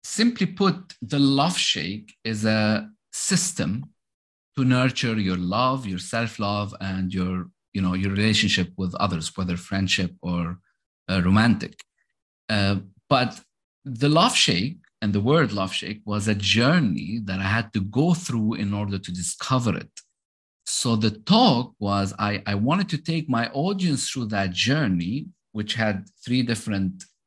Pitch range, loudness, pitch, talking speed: 95-130 Hz, -23 LUFS, 105 Hz, 150 wpm